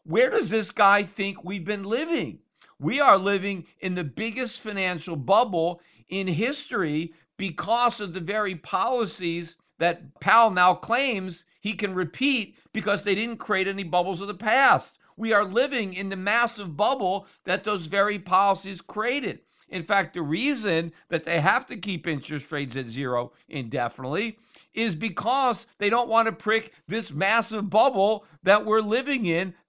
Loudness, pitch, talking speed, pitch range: -25 LUFS, 200 Hz, 160 wpm, 175-225 Hz